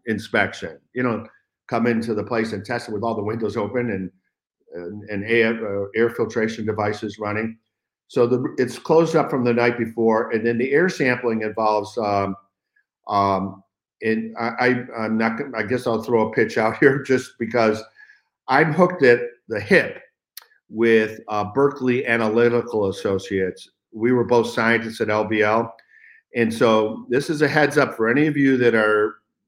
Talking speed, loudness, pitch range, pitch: 175 wpm, -21 LUFS, 110-125 Hz, 115 Hz